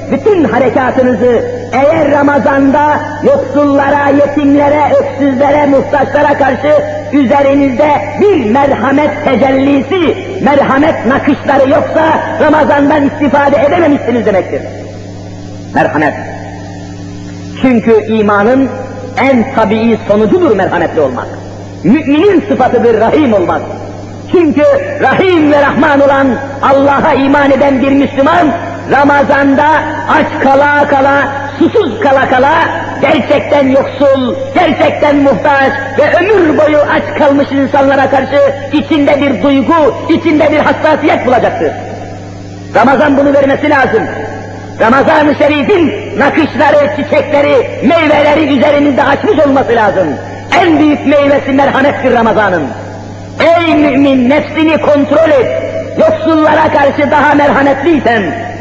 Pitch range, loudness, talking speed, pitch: 265-295 Hz, -8 LUFS, 95 wpm, 280 Hz